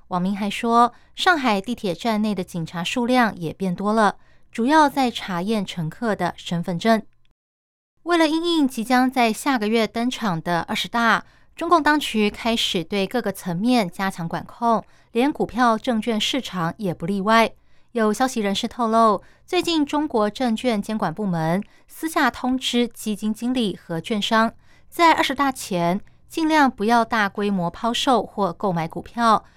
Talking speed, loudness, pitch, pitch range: 240 characters per minute, -21 LUFS, 220 Hz, 195-245 Hz